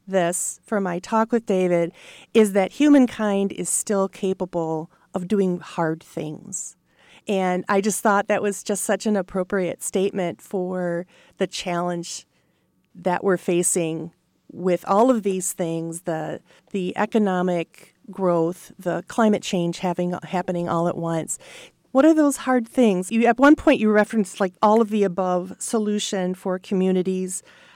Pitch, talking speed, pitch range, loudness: 190 Hz, 150 wpm, 180-210 Hz, -22 LUFS